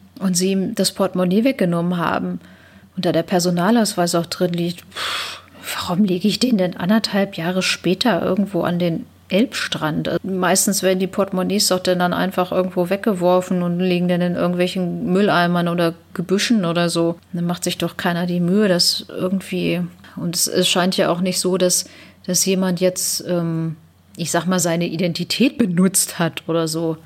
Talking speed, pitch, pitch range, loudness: 170 wpm, 180 Hz, 170-190 Hz, -19 LUFS